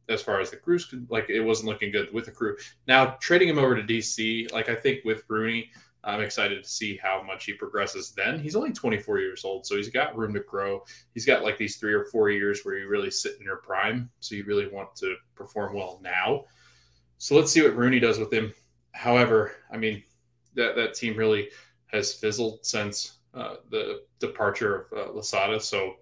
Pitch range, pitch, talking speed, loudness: 105-135 Hz, 115 Hz, 210 wpm, -26 LUFS